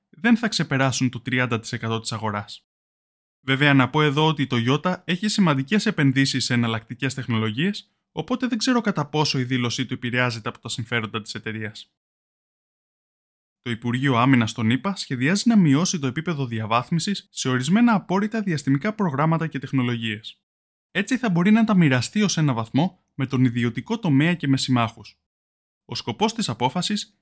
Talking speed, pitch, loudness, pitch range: 160 wpm, 135 Hz, -22 LUFS, 120-185 Hz